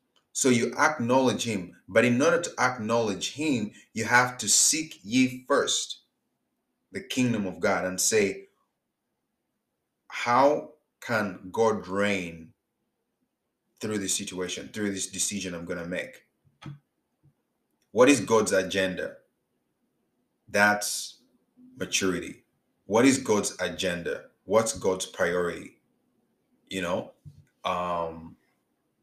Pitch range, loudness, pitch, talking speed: 95-125 Hz, -26 LUFS, 105 Hz, 105 wpm